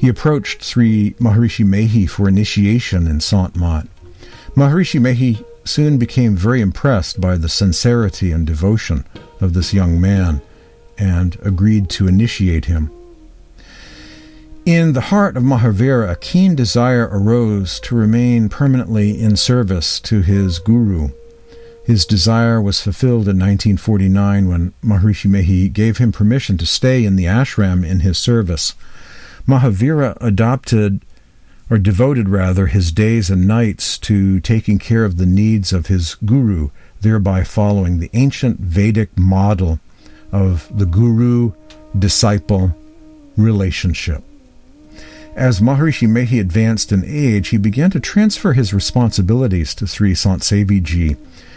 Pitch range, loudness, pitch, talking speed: 95-120 Hz, -15 LUFS, 105 Hz, 130 wpm